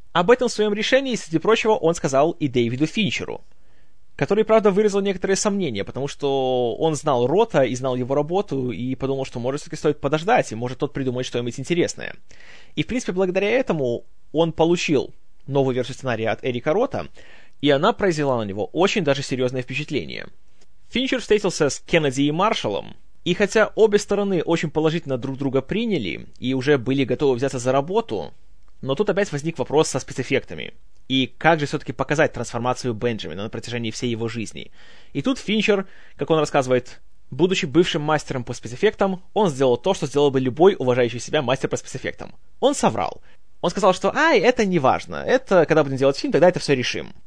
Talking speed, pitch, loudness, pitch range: 180 wpm, 150 Hz, -21 LUFS, 130-190 Hz